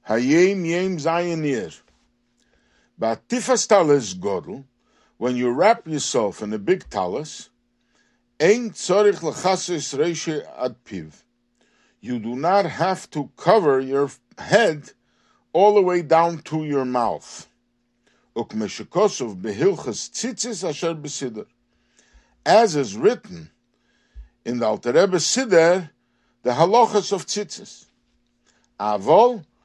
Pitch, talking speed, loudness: 150 Hz, 105 wpm, -21 LUFS